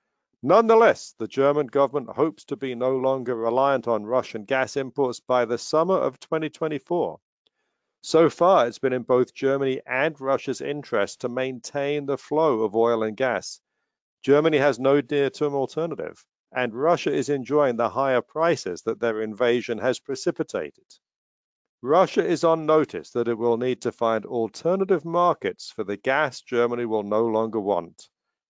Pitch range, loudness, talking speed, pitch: 120-150 Hz, -23 LUFS, 155 wpm, 135 Hz